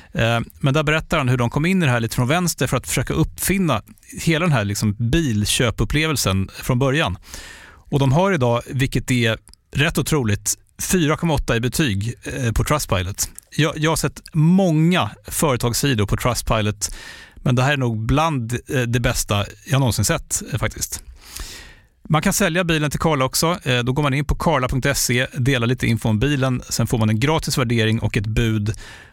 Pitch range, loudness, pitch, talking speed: 115-155 Hz, -20 LUFS, 130 Hz, 175 wpm